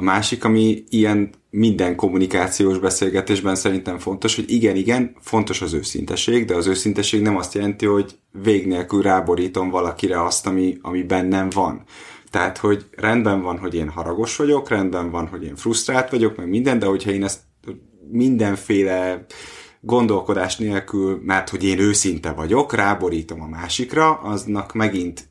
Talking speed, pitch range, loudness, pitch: 150 wpm, 90-110 Hz, -20 LUFS, 95 Hz